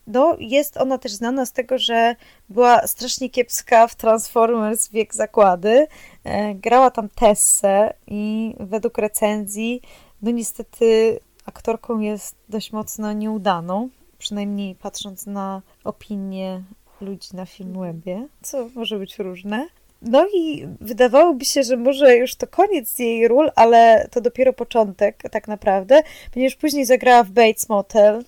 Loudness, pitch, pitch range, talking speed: -18 LUFS, 230 Hz, 210-255 Hz, 130 wpm